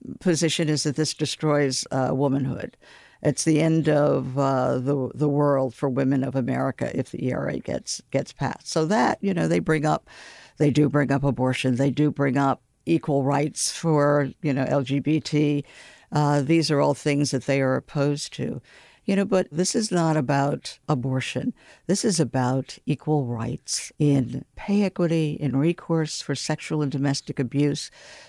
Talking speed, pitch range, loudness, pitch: 170 wpm, 135-160 Hz, -24 LUFS, 145 Hz